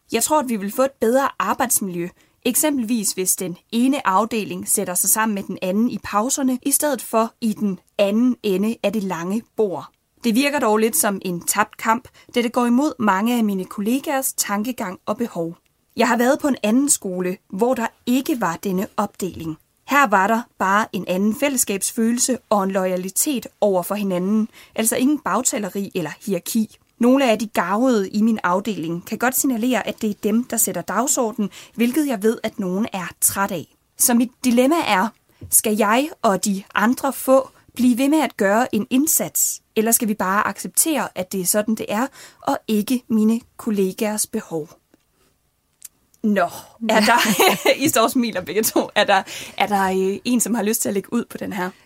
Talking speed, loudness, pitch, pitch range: 190 wpm, -20 LUFS, 220 Hz, 195-245 Hz